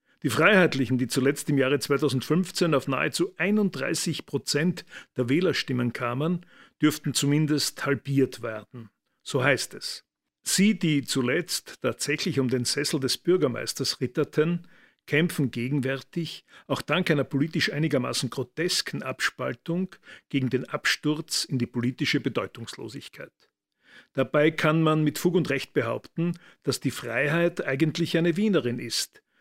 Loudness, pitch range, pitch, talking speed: -26 LUFS, 135-170 Hz, 145 Hz, 125 wpm